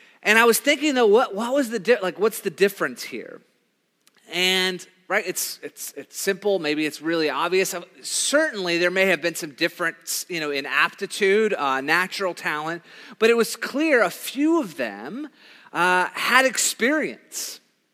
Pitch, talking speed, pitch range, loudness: 195 Hz, 165 wpm, 175-235 Hz, -22 LUFS